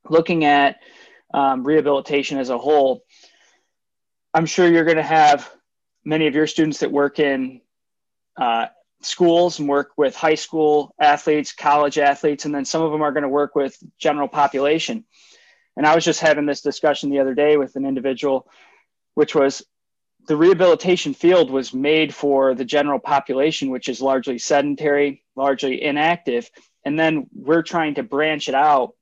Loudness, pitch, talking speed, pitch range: -19 LUFS, 145 Hz, 165 wpm, 140-160 Hz